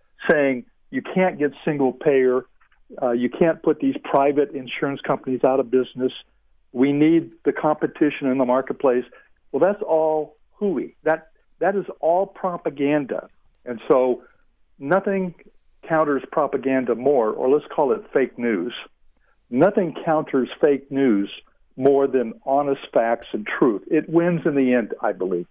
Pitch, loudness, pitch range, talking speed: 140 Hz, -21 LUFS, 130-160 Hz, 145 wpm